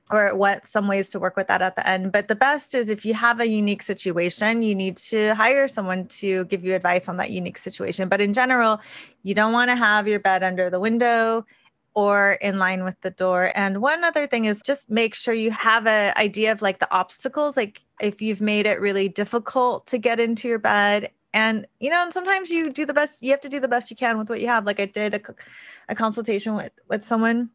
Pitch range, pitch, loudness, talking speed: 200-235 Hz, 215 Hz, -22 LUFS, 240 wpm